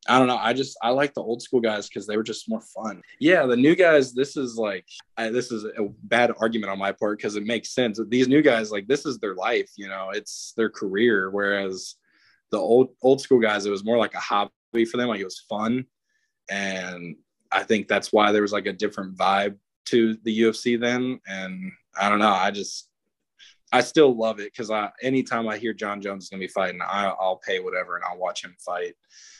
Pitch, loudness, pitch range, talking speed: 110 Hz, -24 LUFS, 100-125 Hz, 230 wpm